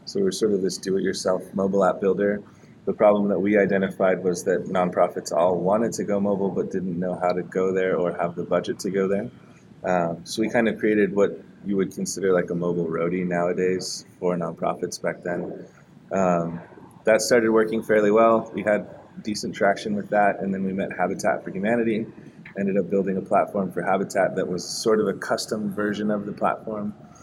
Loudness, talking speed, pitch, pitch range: -24 LUFS, 200 wpm, 100 Hz, 90-105 Hz